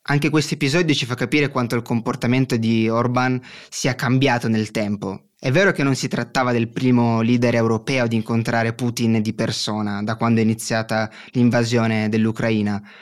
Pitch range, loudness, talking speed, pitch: 110-130 Hz, -20 LUFS, 165 wpm, 120 Hz